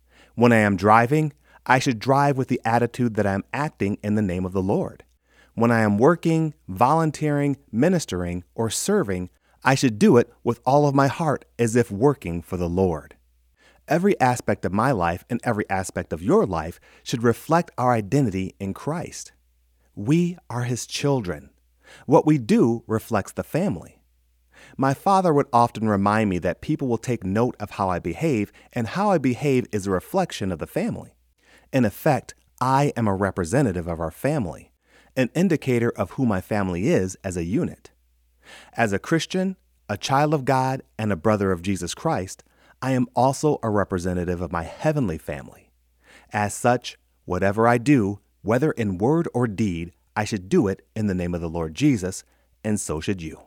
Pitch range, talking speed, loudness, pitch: 90-135 Hz, 180 wpm, -23 LUFS, 110 Hz